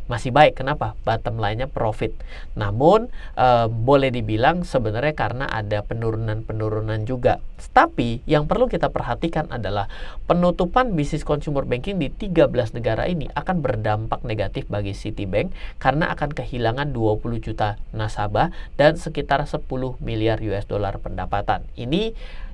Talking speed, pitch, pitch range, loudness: 130 wpm, 120 Hz, 110-145 Hz, -22 LUFS